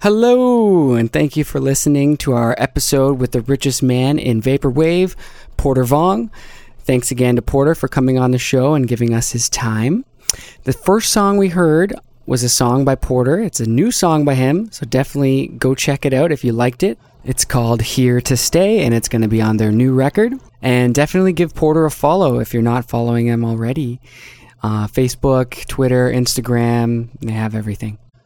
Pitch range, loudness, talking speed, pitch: 120-150 Hz, -15 LUFS, 190 wpm, 130 Hz